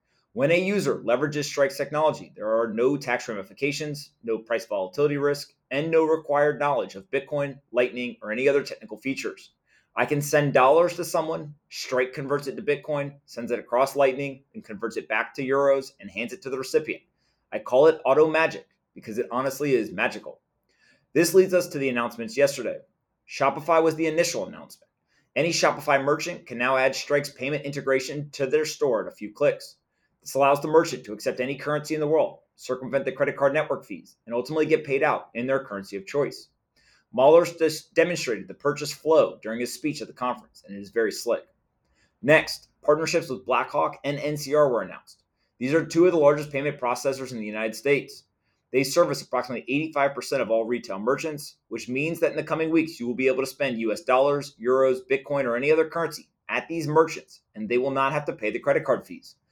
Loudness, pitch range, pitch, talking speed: -25 LUFS, 125-155 Hz, 140 Hz, 200 wpm